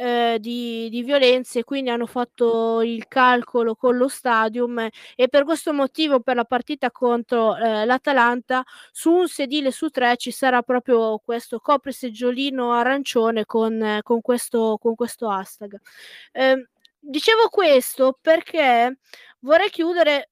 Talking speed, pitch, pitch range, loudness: 135 wpm, 245 Hz, 235-275 Hz, -20 LUFS